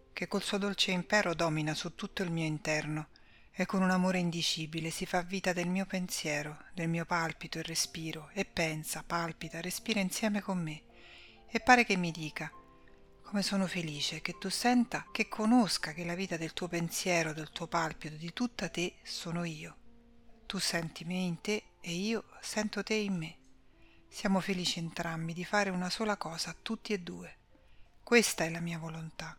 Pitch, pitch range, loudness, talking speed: 175 Hz, 160-195 Hz, -33 LUFS, 180 wpm